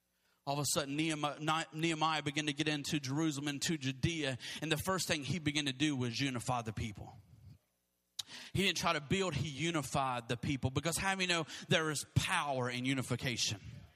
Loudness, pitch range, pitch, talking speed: -35 LUFS, 130-160 Hz, 145 Hz, 195 wpm